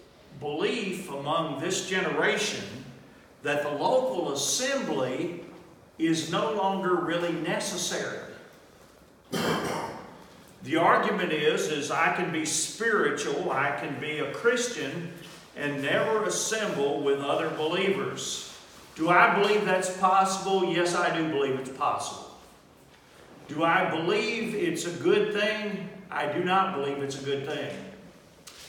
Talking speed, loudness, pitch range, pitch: 120 wpm, -27 LUFS, 155-205 Hz, 175 Hz